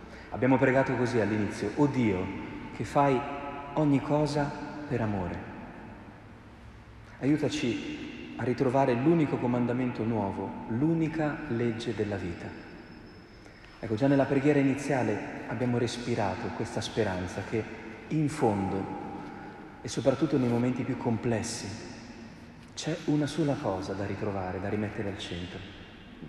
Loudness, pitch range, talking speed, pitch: -30 LUFS, 105-140 Hz, 115 wpm, 120 Hz